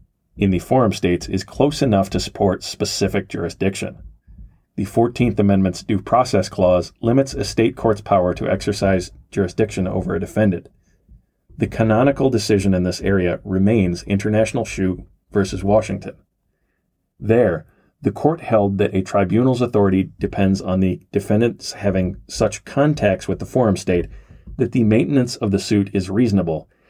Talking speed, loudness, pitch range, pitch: 145 wpm, -19 LUFS, 95-110 Hz, 100 Hz